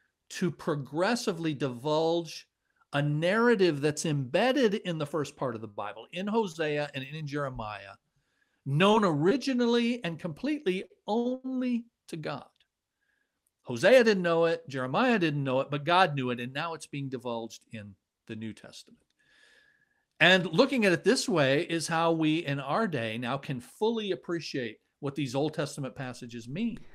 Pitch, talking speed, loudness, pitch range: 165 Hz, 155 wpm, -28 LUFS, 140-205 Hz